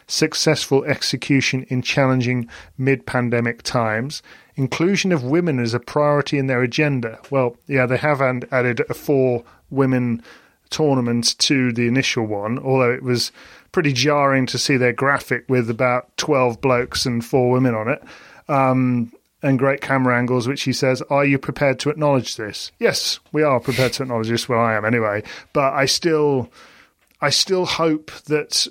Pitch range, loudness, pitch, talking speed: 125-140 Hz, -19 LUFS, 130 Hz, 165 wpm